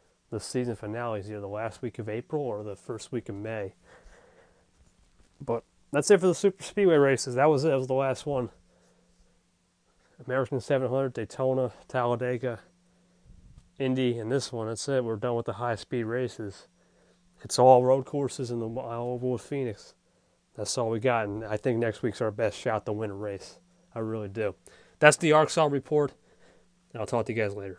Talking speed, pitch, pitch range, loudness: 190 wpm, 125 Hz, 110-135 Hz, -28 LUFS